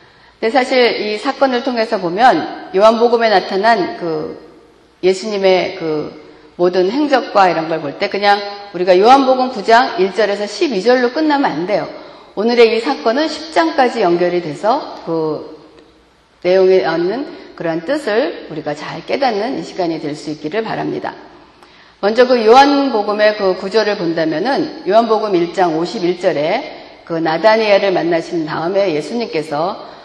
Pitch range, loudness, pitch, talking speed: 175-260 Hz, -15 LUFS, 210 Hz, 285 characters per minute